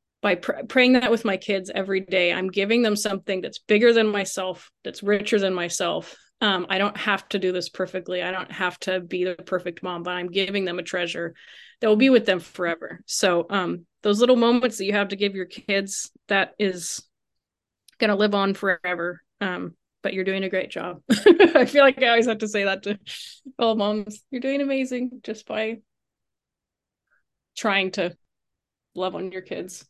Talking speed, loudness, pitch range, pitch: 195 wpm, -23 LUFS, 185-220 Hz, 195 Hz